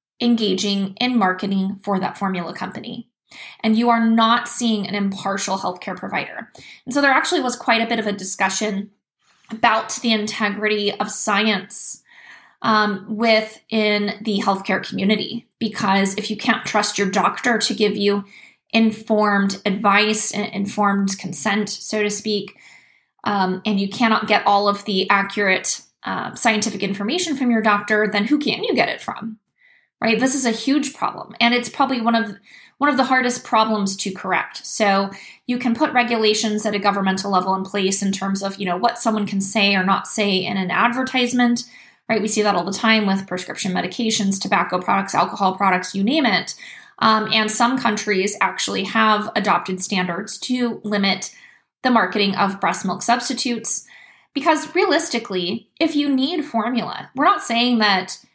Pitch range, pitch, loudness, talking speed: 200-235 Hz, 215 Hz, -19 LUFS, 170 wpm